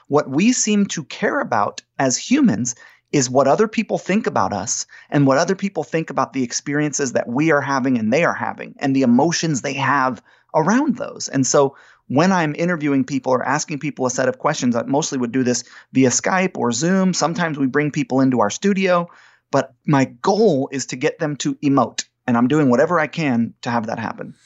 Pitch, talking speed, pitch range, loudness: 145 Hz, 210 wpm, 135-175 Hz, -19 LUFS